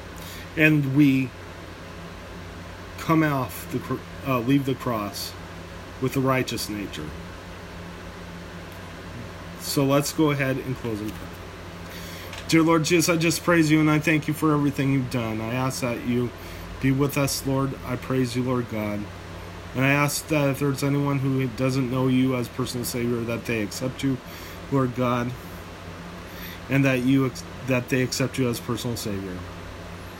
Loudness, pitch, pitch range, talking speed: -24 LUFS, 120 Hz, 90-135 Hz, 160 wpm